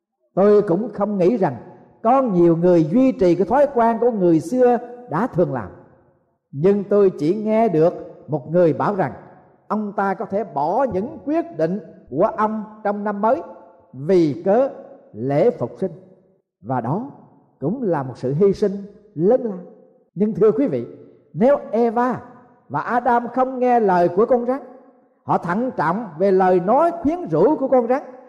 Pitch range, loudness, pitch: 175-245 Hz, -19 LUFS, 205 Hz